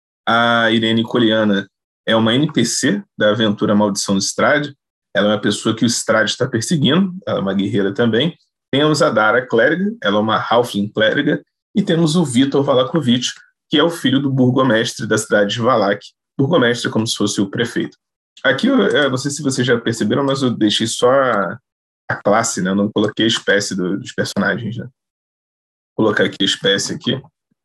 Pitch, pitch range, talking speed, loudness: 115 Hz, 105-135 Hz, 190 wpm, -16 LUFS